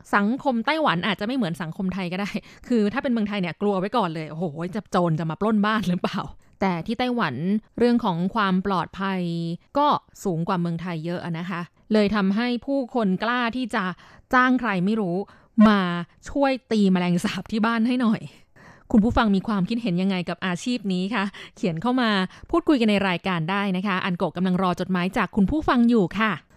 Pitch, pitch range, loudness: 200 Hz, 185-230 Hz, -23 LUFS